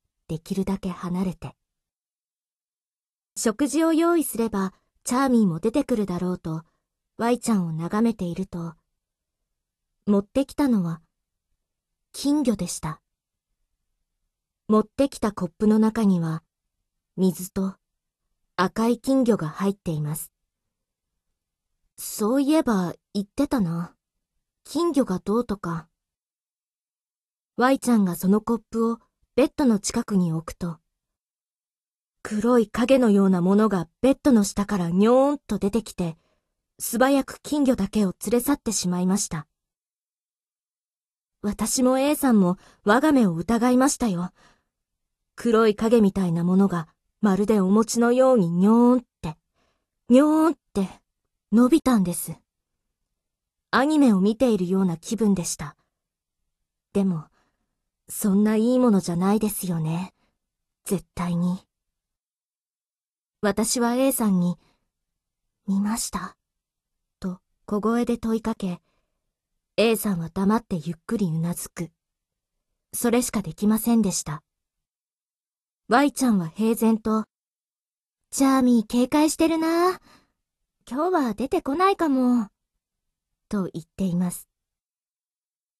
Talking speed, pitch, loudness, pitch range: 235 characters per minute, 205 Hz, -23 LUFS, 175-240 Hz